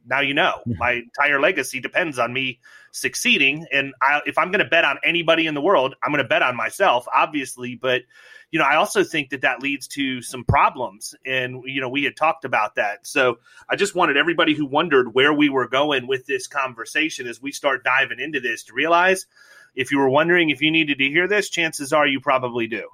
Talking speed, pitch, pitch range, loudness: 225 wpm, 145 Hz, 130-170 Hz, -20 LUFS